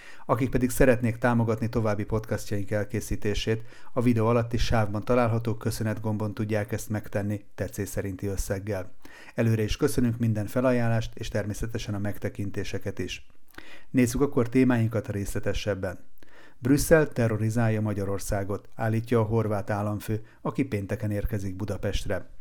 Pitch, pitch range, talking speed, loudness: 110 Hz, 100-120 Hz, 120 wpm, -28 LUFS